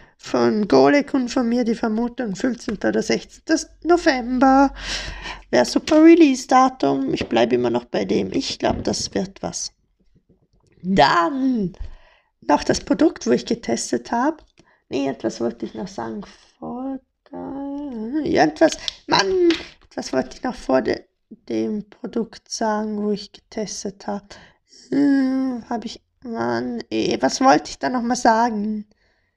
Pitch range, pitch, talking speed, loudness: 195-280 Hz, 240 Hz, 140 wpm, -20 LUFS